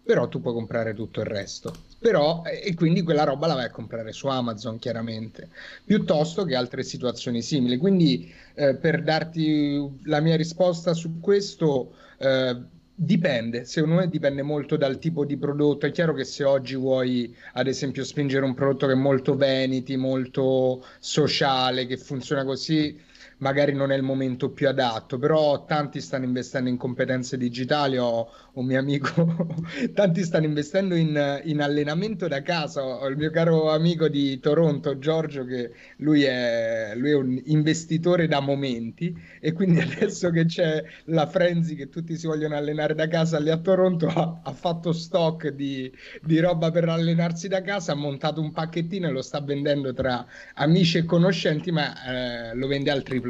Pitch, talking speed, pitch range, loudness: 145 Hz, 170 wpm, 130-165 Hz, -24 LUFS